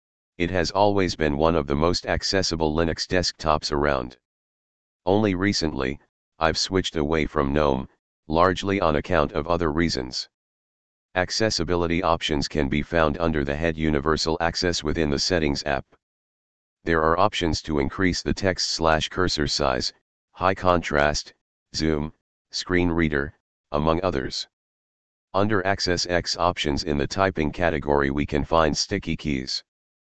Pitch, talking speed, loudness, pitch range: 80 Hz, 140 wpm, -24 LUFS, 75-90 Hz